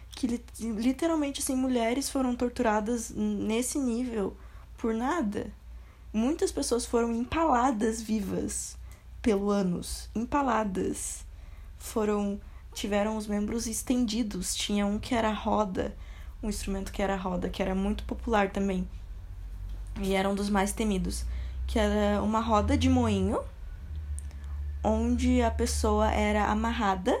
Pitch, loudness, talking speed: 210 Hz, -29 LUFS, 125 wpm